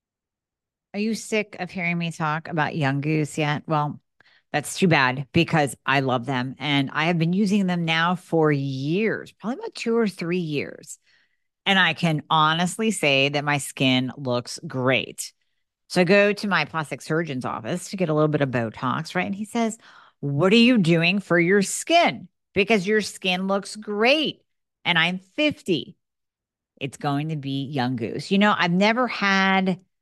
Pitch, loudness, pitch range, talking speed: 170 Hz, -22 LUFS, 145-200 Hz, 180 wpm